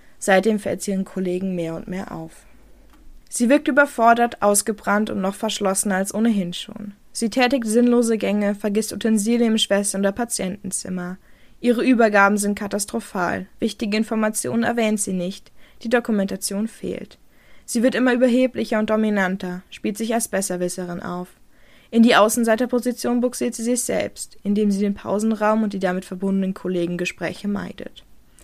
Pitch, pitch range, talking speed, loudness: 210 Hz, 190-230 Hz, 150 wpm, -21 LUFS